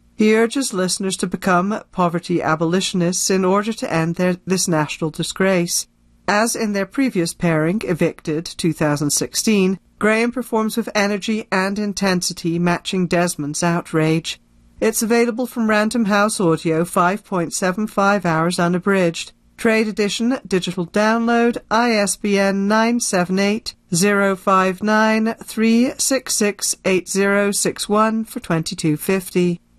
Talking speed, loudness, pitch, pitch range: 135 wpm, -18 LUFS, 195 Hz, 175-215 Hz